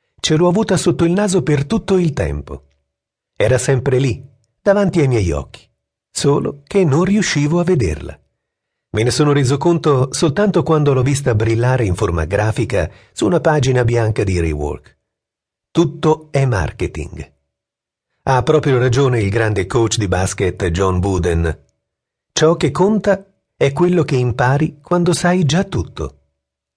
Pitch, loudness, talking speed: 130 Hz, -16 LUFS, 150 wpm